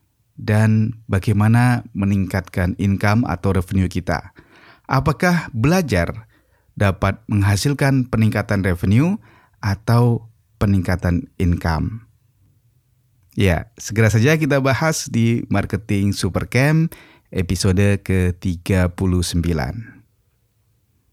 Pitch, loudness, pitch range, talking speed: 105 Hz, -19 LUFS, 95-120 Hz, 75 wpm